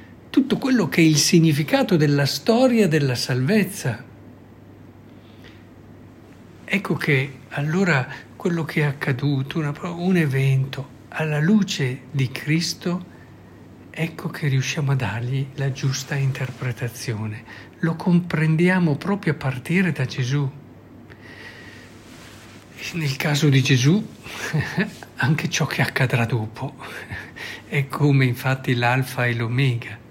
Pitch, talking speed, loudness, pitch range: 135 Hz, 110 wpm, -21 LUFS, 125-160 Hz